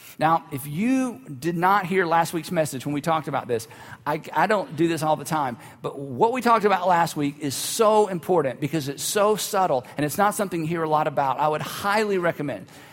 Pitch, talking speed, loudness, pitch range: 160 Hz, 230 wpm, -23 LUFS, 145-190 Hz